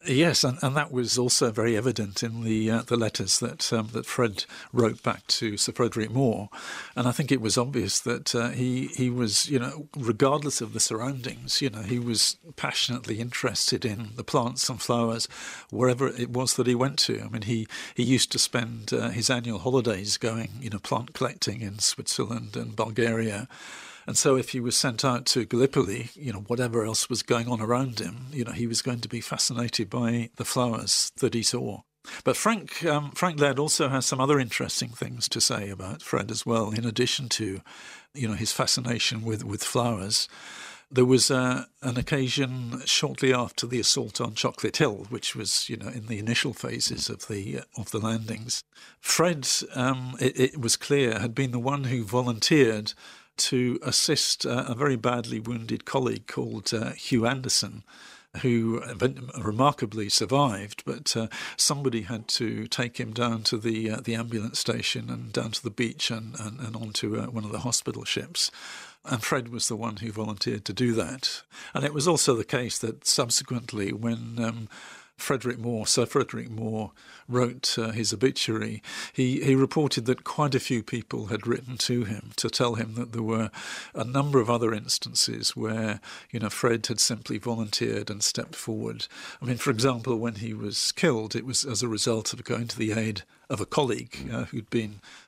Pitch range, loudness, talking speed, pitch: 110-130 Hz, -26 LUFS, 190 wpm, 120 Hz